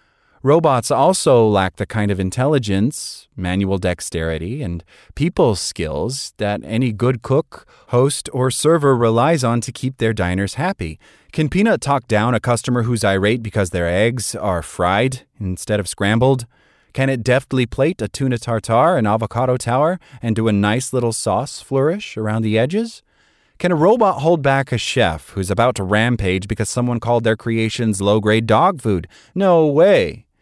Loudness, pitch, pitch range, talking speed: -18 LUFS, 115 Hz, 105-135 Hz, 165 wpm